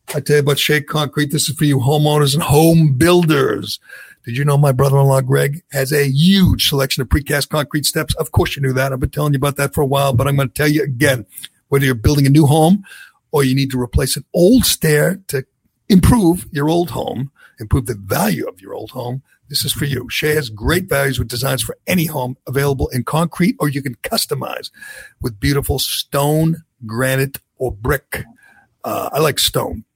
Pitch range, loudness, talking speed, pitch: 135-150 Hz, -16 LUFS, 210 wpm, 140 Hz